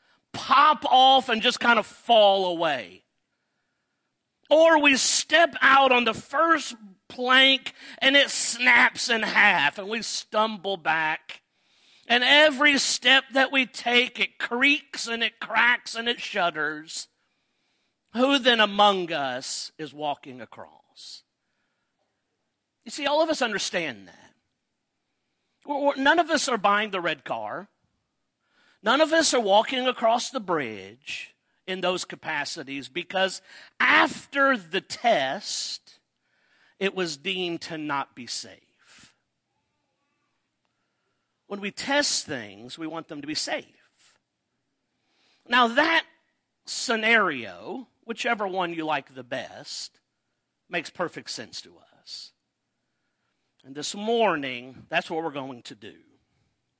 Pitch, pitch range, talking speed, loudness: 230 Hz, 175-270 Hz, 125 wpm, -22 LUFS